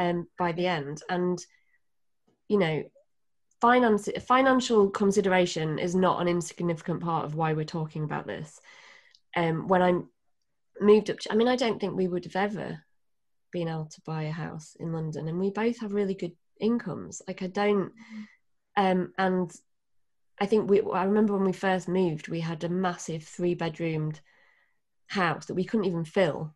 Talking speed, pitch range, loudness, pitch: 175 wpm, 165-205 Hz, -28 LUFS, 180 Hz